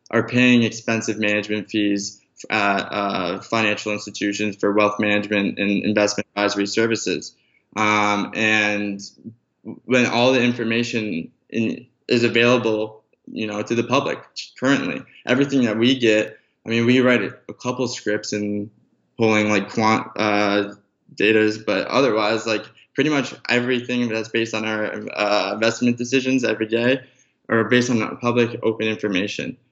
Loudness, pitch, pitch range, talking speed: -20 LUFS, 110 Hz, 105-120 Hz, 140 wpm